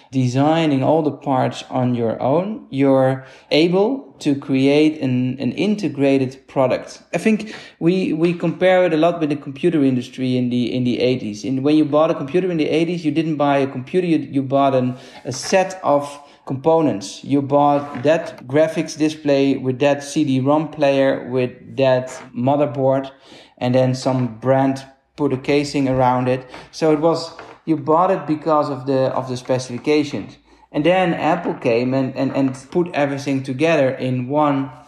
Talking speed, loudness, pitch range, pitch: 170 wpm, -19 LUFS, 130-155 Hz, 140 Hz